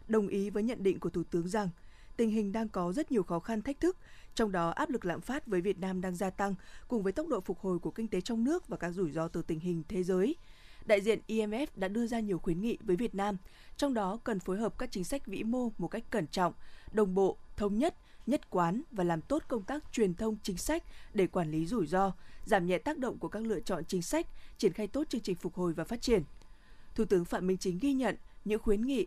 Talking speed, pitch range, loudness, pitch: 260 wpm, 185-230 Hz, -34 LUFS, 205 Hz